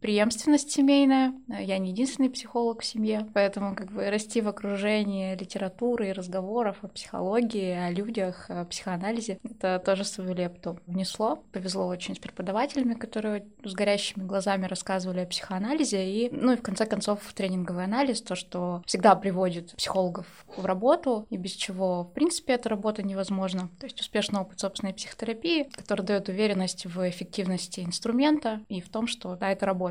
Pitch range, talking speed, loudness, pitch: 190-230 Hz, 165 wpm, -28 LUFS, 200 Hz